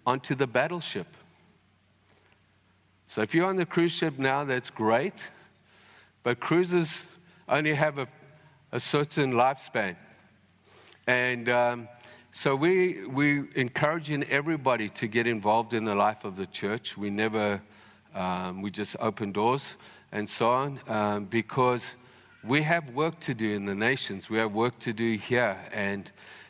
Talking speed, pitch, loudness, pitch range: 145 wpm, 120 Hz, -28 LUFS, 105-145 Hz